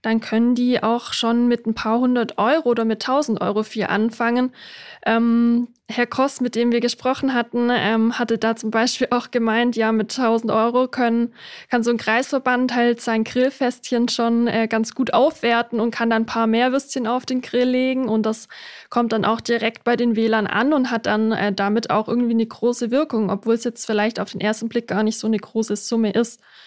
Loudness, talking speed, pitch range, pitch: -20 LUFS, 210 wpm, 225-245 Hz, 235 Hz